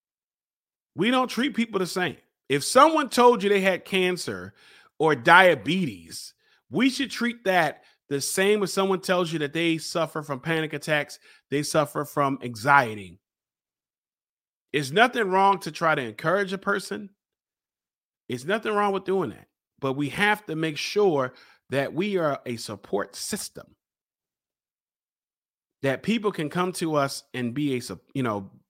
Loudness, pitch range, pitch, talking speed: -24 LUFS, 140-200 Hz, 165 Hz, 155 wpm